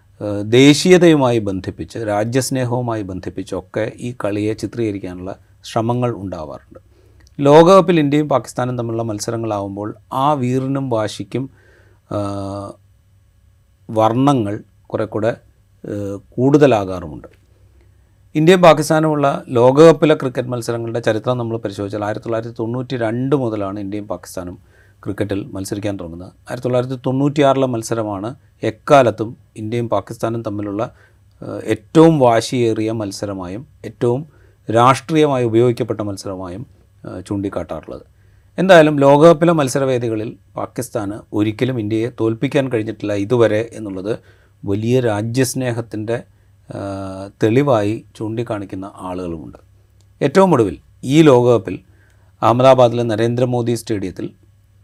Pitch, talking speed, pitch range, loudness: 110 Hz, 80 wpm, 100-125 Hz, -16 LUFS